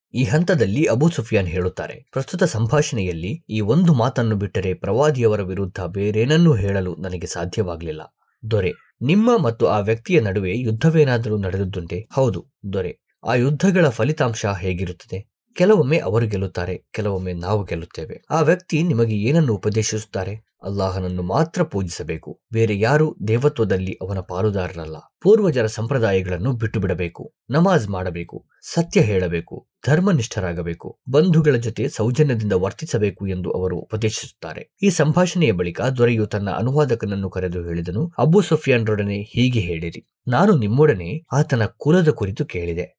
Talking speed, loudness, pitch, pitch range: 115 wpm, -20 LUFS, 110 Hz, 95-150 Hz